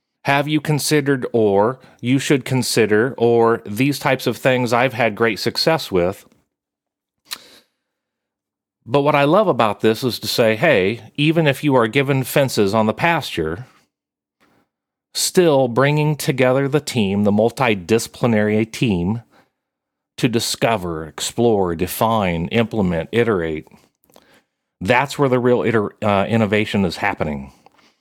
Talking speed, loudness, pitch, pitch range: 120 wpm, -18 LUFS, 115 Hz, 105-140 Hz